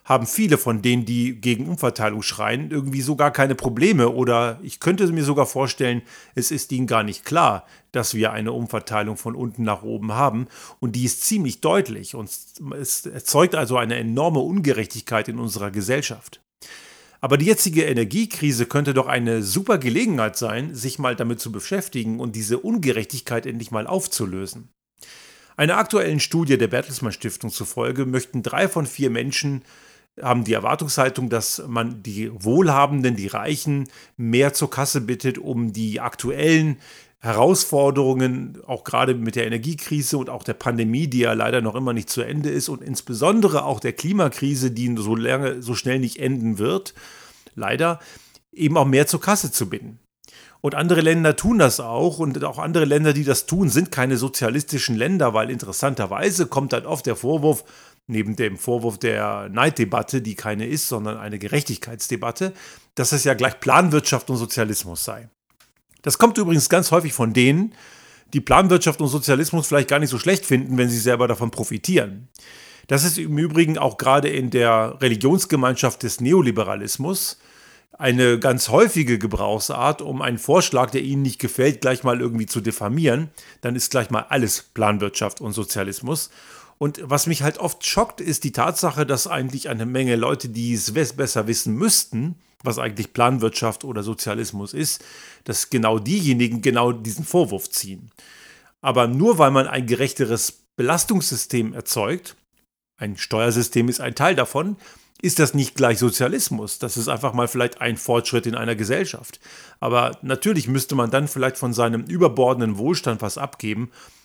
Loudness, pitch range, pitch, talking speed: -21 LUFS, 115-150 Hz, 130 Hz, 160 wpm